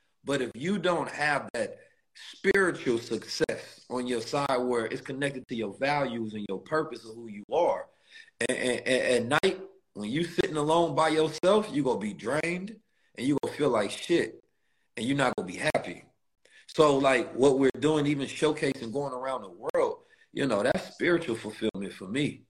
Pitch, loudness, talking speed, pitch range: 150 Hz, -28 LUFS, 185 wpm, 125-190 Hz